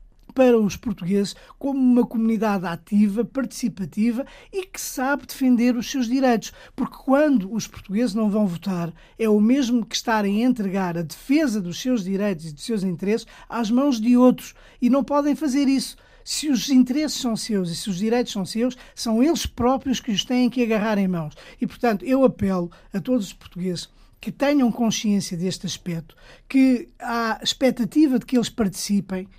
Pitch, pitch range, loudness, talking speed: 230 Hz, 200-255 Hz, -22 LUFS, 180 wpm